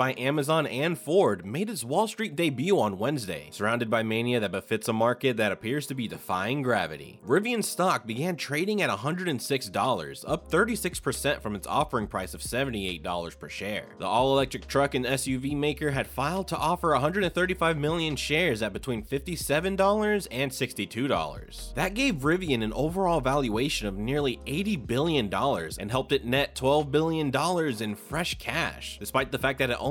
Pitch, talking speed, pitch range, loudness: 140 Hz, 165 wpm, 120-165 Hz, -28 LUFS